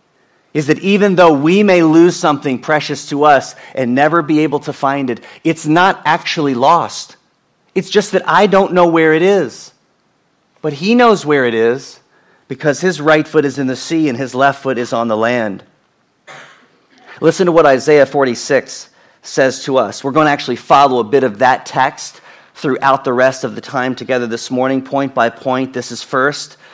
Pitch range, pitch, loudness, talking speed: 130-165 Hz, 145 Hz, -13 LUFS, 195 wpm